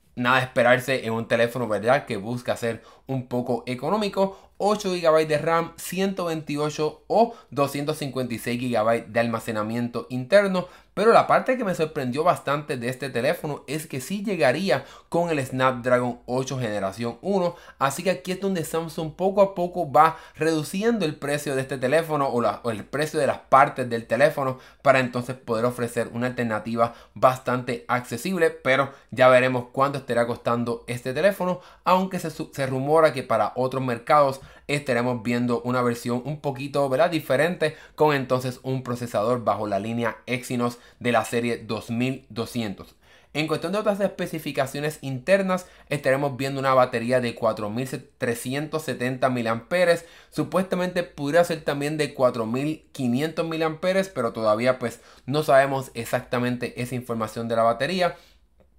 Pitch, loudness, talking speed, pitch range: 135 Hz, -24 LUFS, 150 wpm, 120-160 Hz